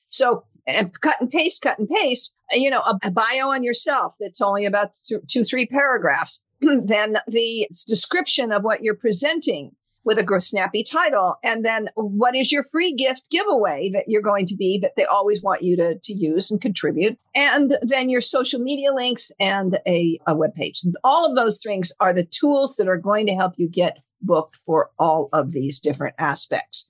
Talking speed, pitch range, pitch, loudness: 200 wpm, 190-260 Hz, 215 Hz, -20 LUFS